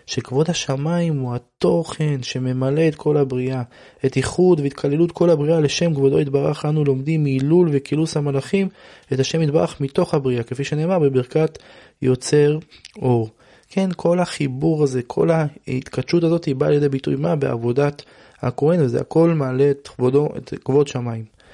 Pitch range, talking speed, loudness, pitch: 130-160 Hz, 150 wpm, -20 LUFS, 145 Hz